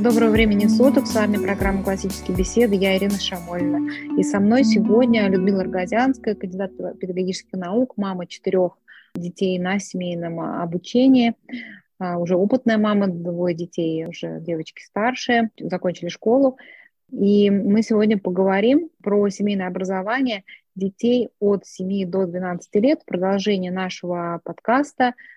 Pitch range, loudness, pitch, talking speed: 185-230 Hz, -21 LUFS, 200 Hz, 125 wpm